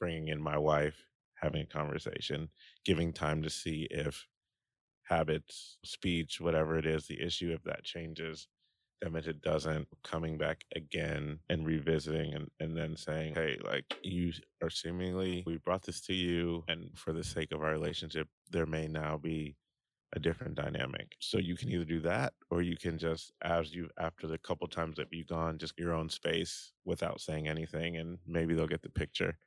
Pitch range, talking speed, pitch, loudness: 80-85 Hz, 185 wpm, 80 Hz, -37 LUFS